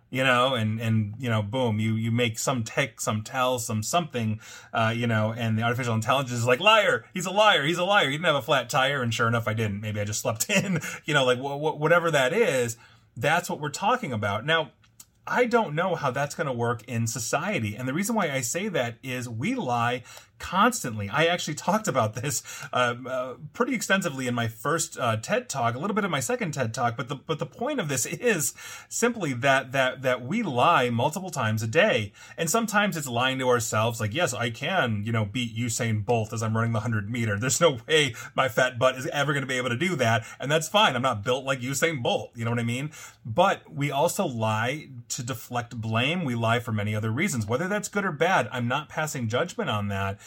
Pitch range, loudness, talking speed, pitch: 115-160 Hz, -25 LUFS, 235 wpm, 125 Hz